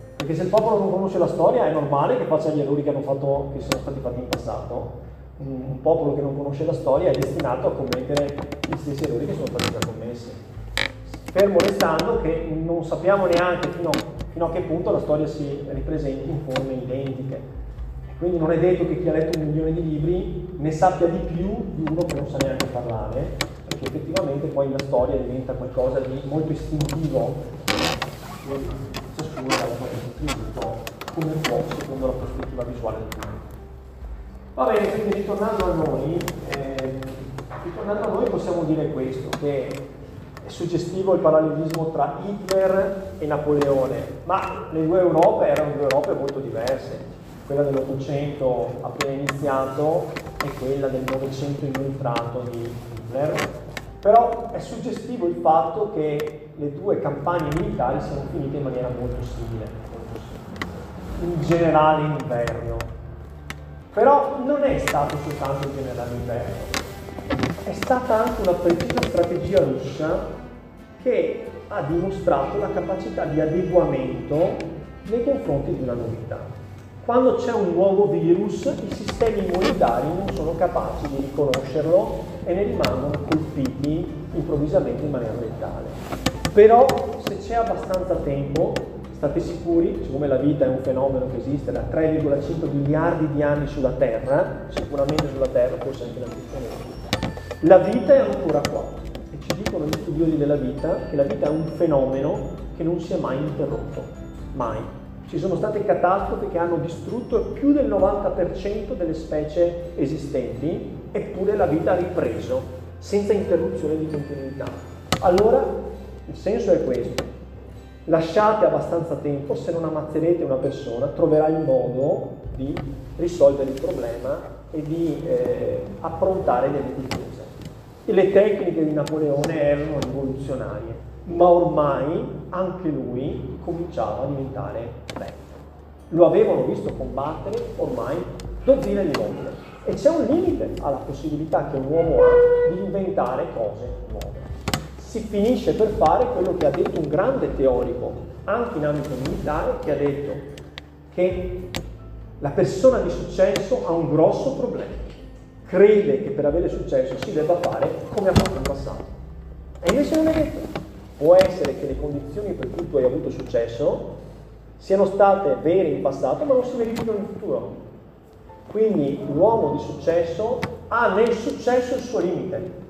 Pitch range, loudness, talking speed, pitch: 135-180 Hz, -23 LUFS, 150 wpm, 155 Hz